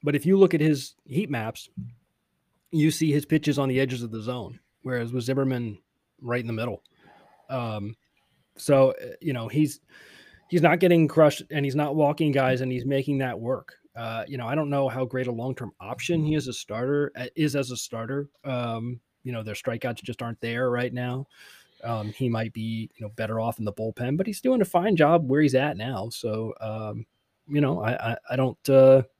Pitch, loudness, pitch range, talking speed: 130 Hz, -26 LUFS, 115-145 Hz, 215 wpm